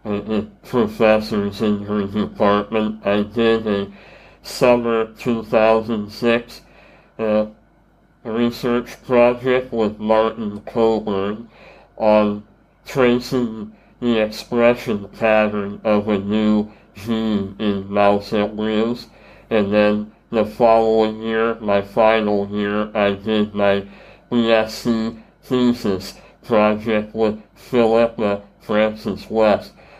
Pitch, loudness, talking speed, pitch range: 110 Hz, -19 LUFS, 90 wpm, 105-115 Hz